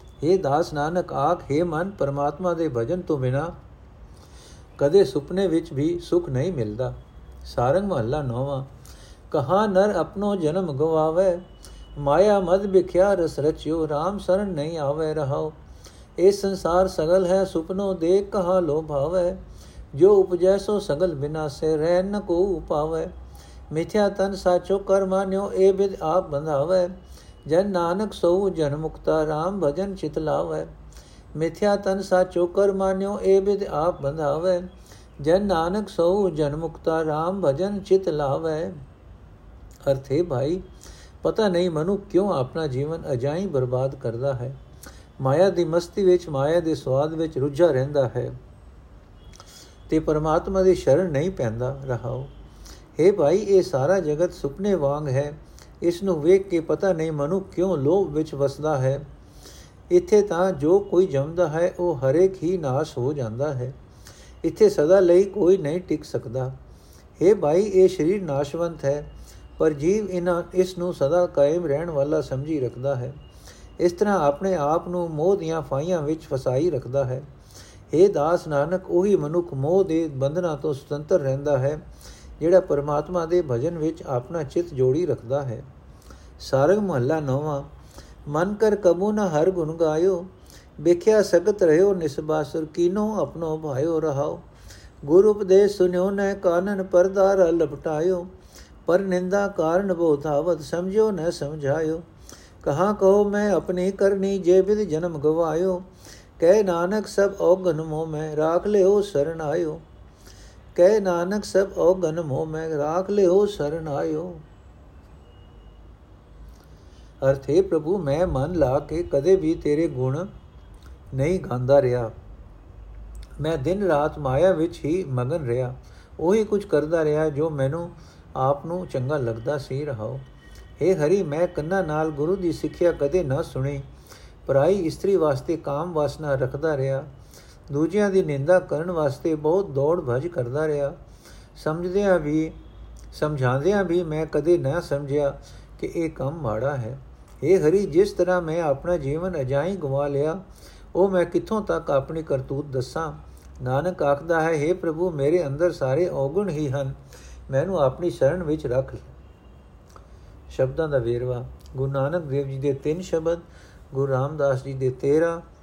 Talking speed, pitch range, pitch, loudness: 145 wpm, 135-185 Hz, 160 Hz, -23 LUFS